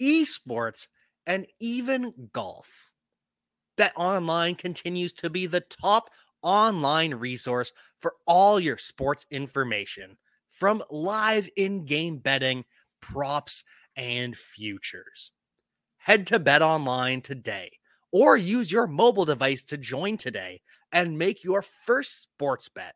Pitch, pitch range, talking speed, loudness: 175 Hz, 135-205 Hz, 110 wpm, -25 LUFS